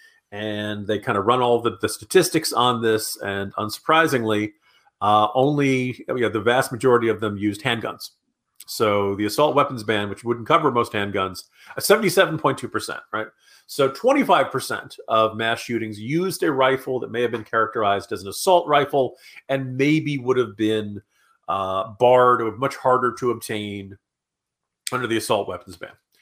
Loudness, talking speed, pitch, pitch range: -21 LUFS, 160 wpm, 120 Hz, 105-135 Hz